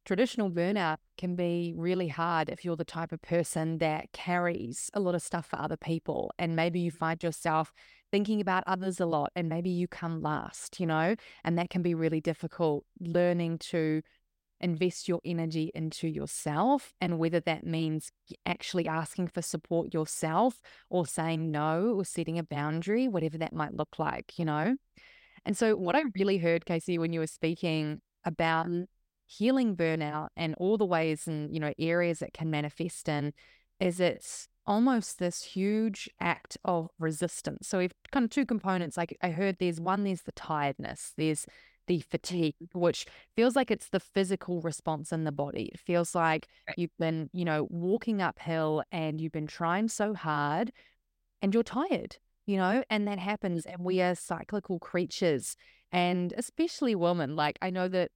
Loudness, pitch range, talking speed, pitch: -31 LUFS, 160-190 Hz, 175 wpm, 170 Hz